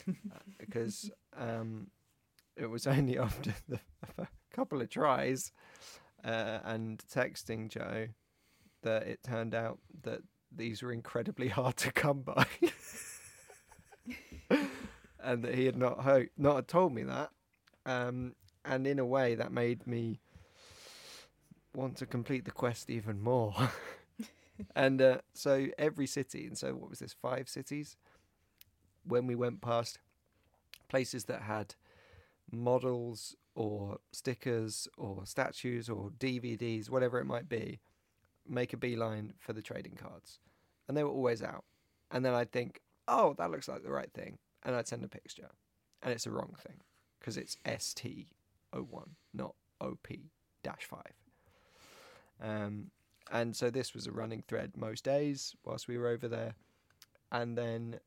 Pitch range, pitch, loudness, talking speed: 110-130 Hz, 120 Hz, -36 LUFS, 145 wpm